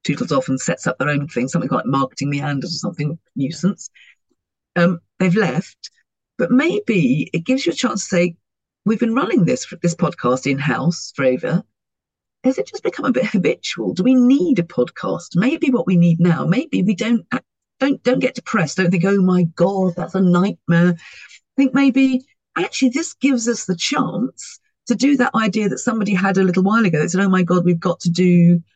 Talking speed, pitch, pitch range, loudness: 205 wpm, 190 Hz, 170-250 Hz, -18 LUFS